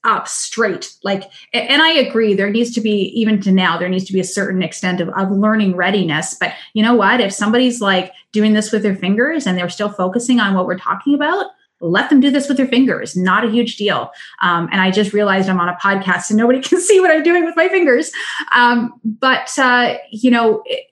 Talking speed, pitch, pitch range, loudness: 230 wpm, 215 Hz, 190-255 Hz, -15 LUFS